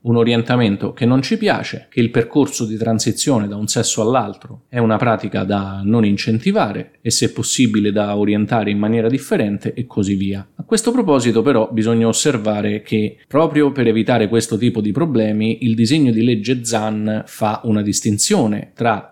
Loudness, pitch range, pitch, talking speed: -17 LUFS, 105-125 Hz, 115 Hz, 175 wpm